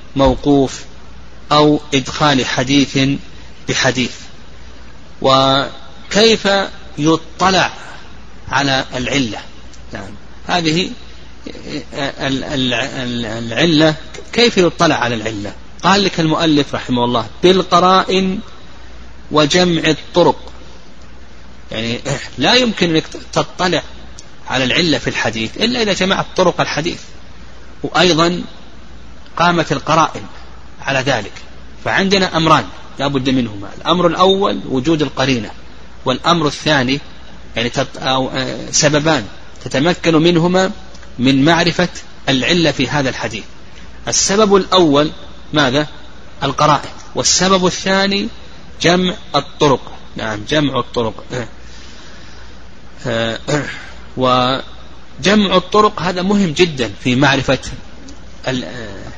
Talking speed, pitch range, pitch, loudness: 85 wpm, 115-170 Hz, 140 Hz, -15 LUFS